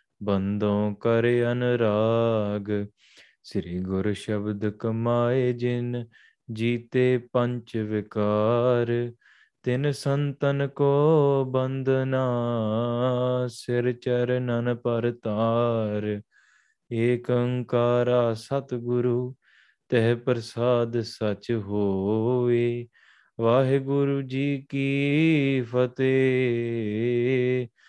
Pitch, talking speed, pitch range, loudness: 120 Hz, 65 wpm, 115-125 Hz, -25 LUFS